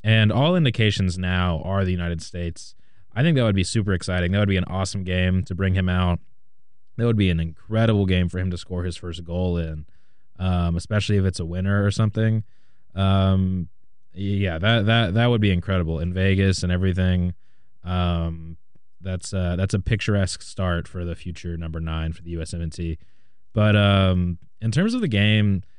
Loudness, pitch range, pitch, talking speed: -23 LUFS, 90-105 Hz, 95 Hz, 190 wpm